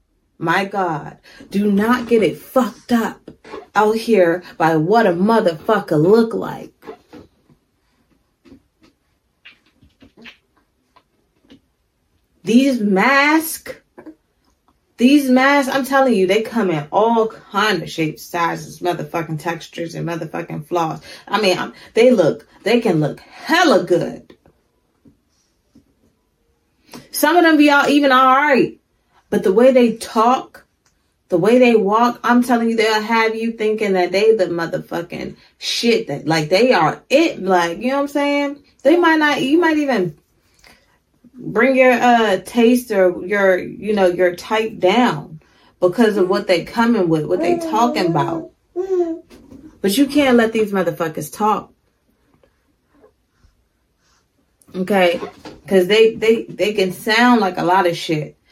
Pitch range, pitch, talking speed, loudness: 185-260 Hz, 220 Hz, 135 wpm, -16 LUFS